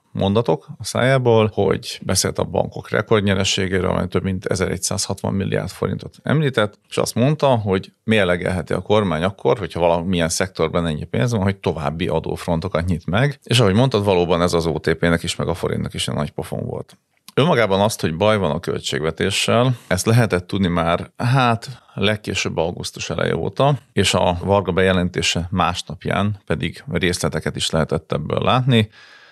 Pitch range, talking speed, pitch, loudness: 85-110 Hz, 160 wpm, 95 Hz, -19 LUFS